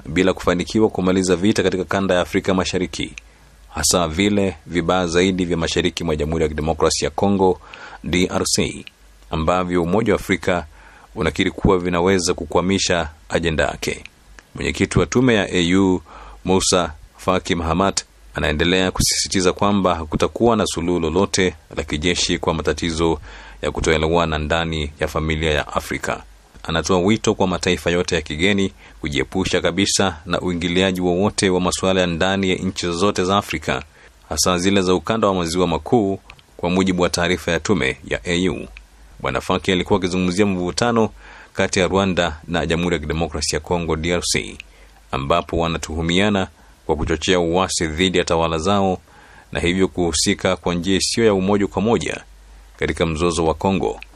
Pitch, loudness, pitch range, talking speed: 90 Hz, -19 LUFS, 80-95 Hz, 145 wpm